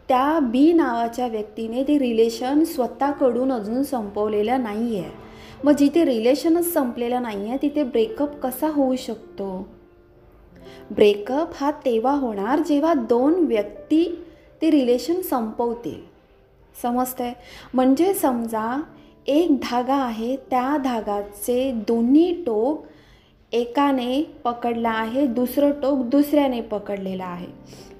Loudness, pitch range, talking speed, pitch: -22 LUFS, 235-290 Hz, 105 wpm, 255 Hz